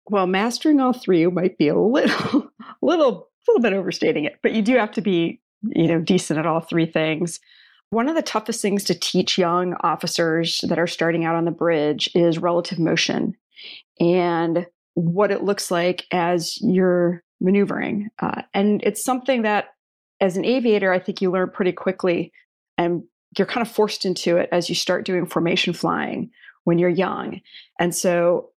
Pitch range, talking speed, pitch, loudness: 170-210 Hz, 180 wpm, 180 Hz, -21 LUFS